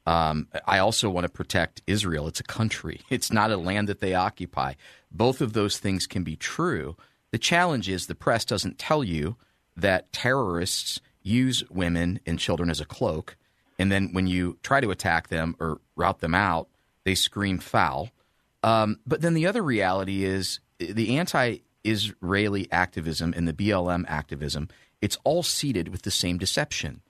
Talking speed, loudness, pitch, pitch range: 175 wpm, -26 LUFS, 95 Hz, 85-110 Hz